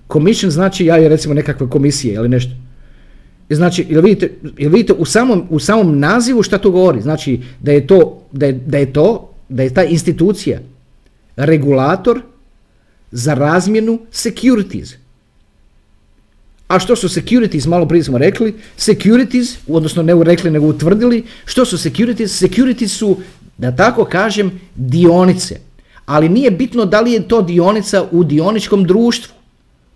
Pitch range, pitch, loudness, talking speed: 145-215 Hz, 175 Hz, -12 LUFS, 145 wpm